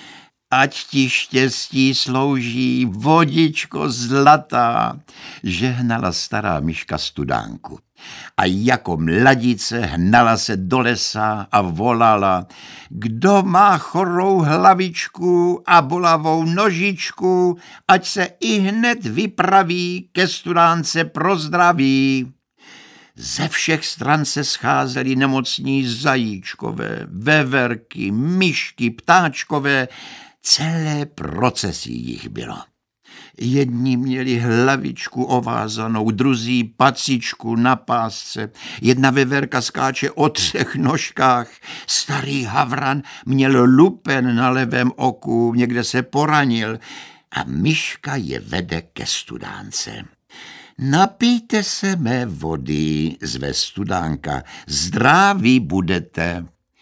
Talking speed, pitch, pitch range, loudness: 90 wpm, 130 Hz, 115-160 Hz, -18 LUFS